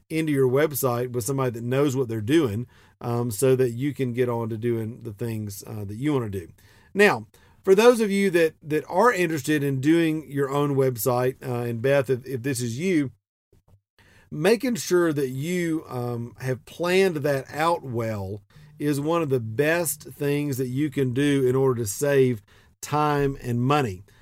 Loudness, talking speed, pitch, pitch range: -24 LUFS, 190 wpm, 135 Hz, 120-150 Hz